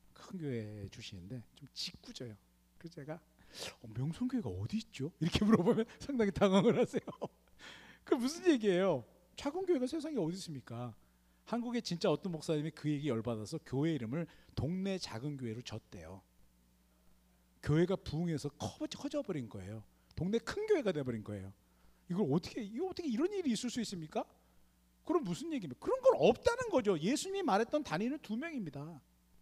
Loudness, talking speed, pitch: -36 LUFS, 360 characters per minute, 160 Hz